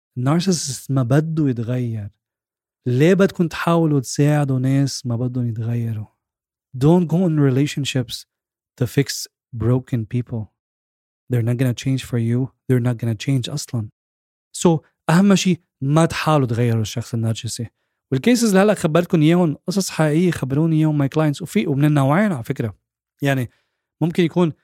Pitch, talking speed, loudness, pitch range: 135 Hz, 140 wpm, -19 LUFS, 120-160 Hz